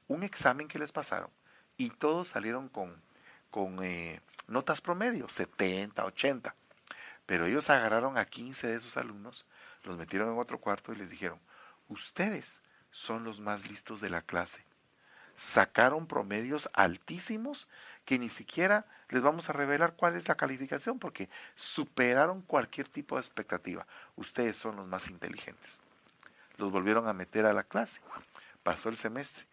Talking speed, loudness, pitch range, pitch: 150 wpm, -32 LUFS, 105-155 Hz, 120 Hz